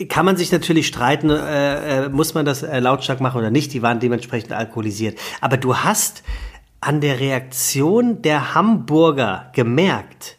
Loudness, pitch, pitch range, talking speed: -18 LUFS, 140 Hz, 120-155 Hz, 160 wpm